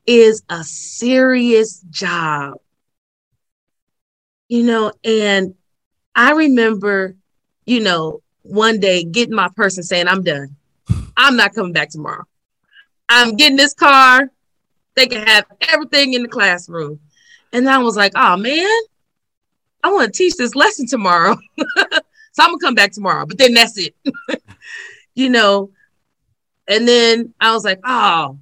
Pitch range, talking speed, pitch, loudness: 190-265 Hz, 140 wpm, 225 Hz, -13 LUFS